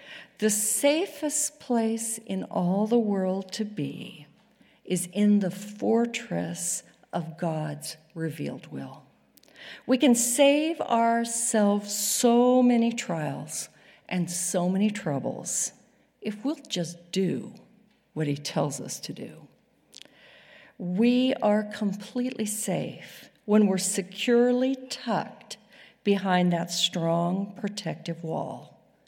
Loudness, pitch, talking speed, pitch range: -26 LUFS, 205 Hz, 105 wpm, 175-235 Hz